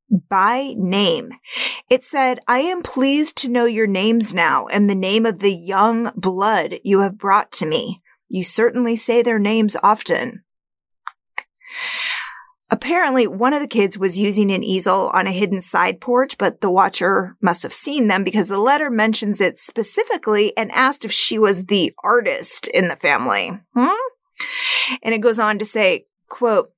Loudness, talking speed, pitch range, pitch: -17 LUFS, 170 wpm, 200-260 Hz, 225 Hz